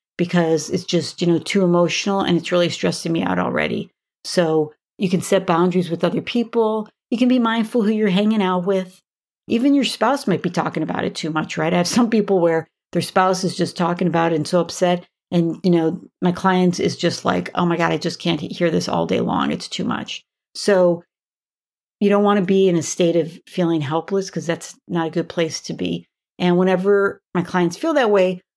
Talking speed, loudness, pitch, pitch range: 225 wpm, -19 LUFS, 180 Hz, 170-195 Hz